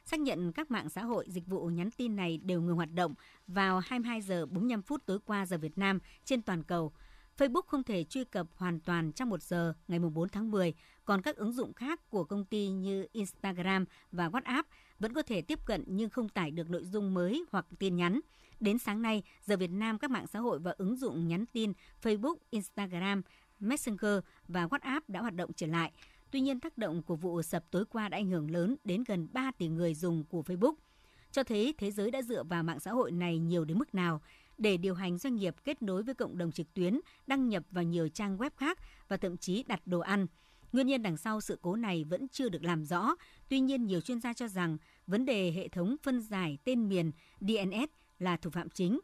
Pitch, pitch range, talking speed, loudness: 195 Hz, 175-240 Hz, 230 wpm, -35 LUFS